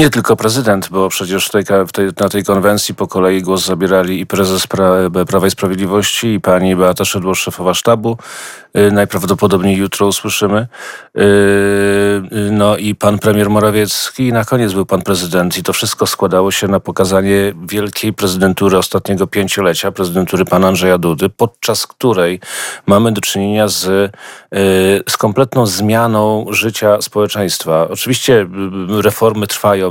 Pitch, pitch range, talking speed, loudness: 100 Hz, 95-105 Hz, 130 wpm, -13 LUFS